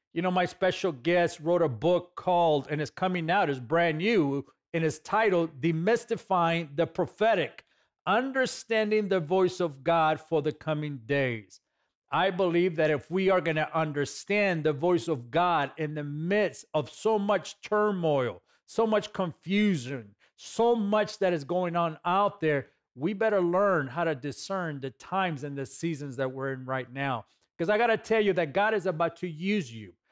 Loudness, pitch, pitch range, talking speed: -28 LUFS, 170 Hz, 150-190 Hz, 180 wpm